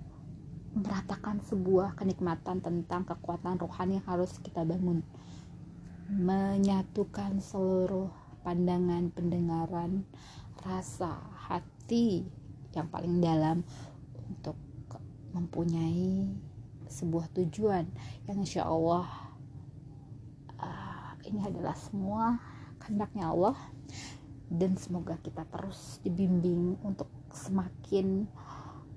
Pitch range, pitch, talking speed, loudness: 140-190 Hz, 175 Hz, 80 wpm, -33 LUFS